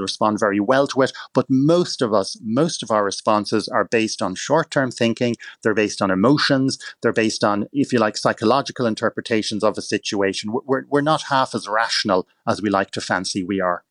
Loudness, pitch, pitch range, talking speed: -20 LUFS, 110 Hz, 105-130 Hz, 205 wpm